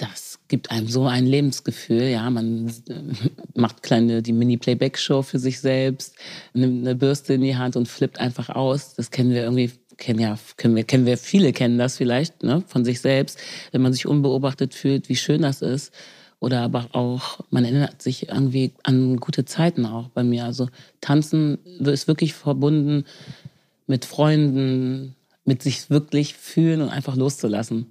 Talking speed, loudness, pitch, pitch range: 170 wpm, -22 LUFS, 130 Hz, 125-140 Hz